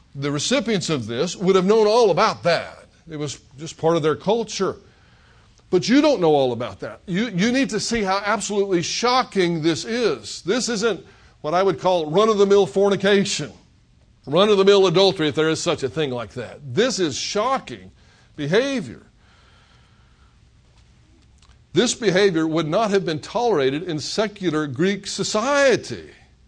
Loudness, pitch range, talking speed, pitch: -20 LUFS, 160-215 Hz, 165 wpm, 190 Hz